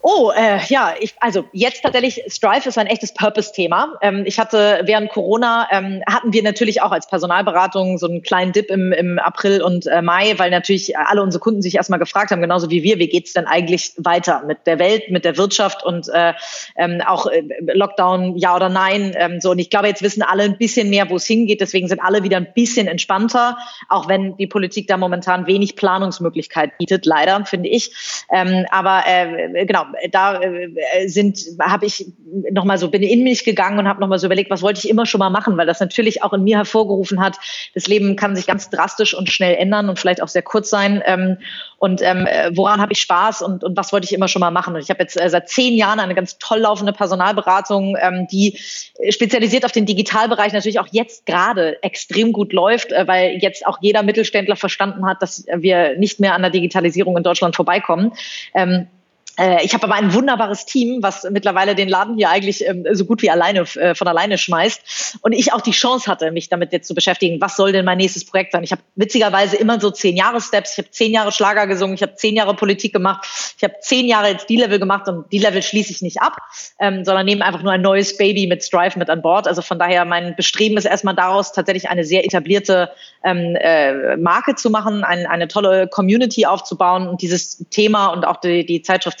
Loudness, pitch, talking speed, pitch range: -16 LUFS, 195 Hz, 215 wpm, 180-210 Hz